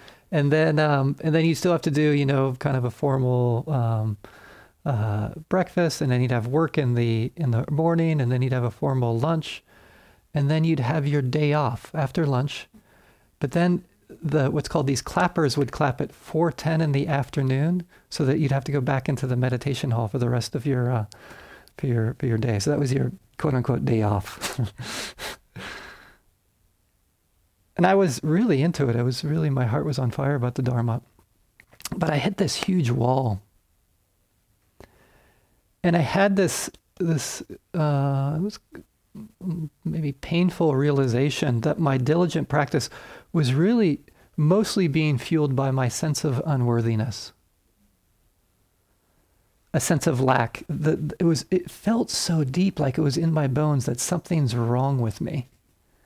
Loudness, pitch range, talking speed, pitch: -24 LUFS, 120-160 Hz, 170 wpm, 140 Hz